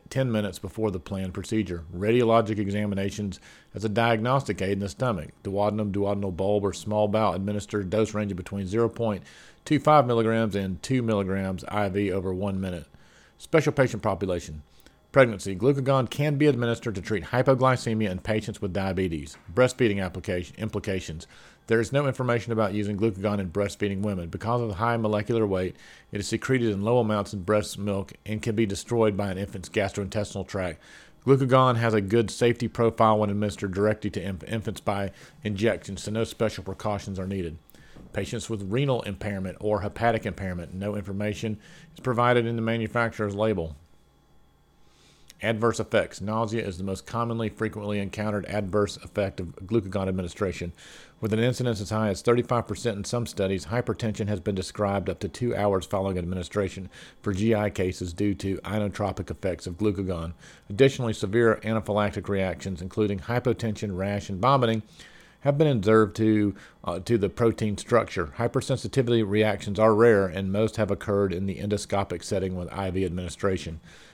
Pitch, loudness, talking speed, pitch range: 105 Hz, -26 LUFS, 160 wpm, 95-115 Hz